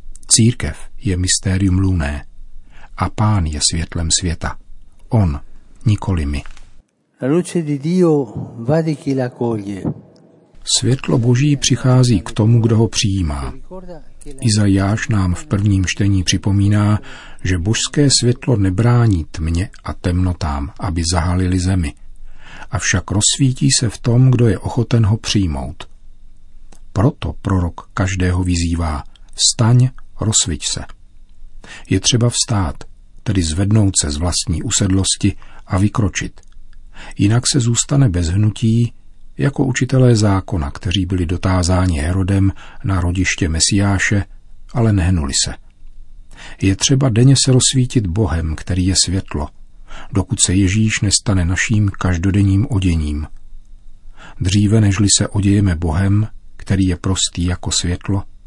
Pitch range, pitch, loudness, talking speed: 90-115 Hz, 100 Hz, -16 LUFS, 110 wpm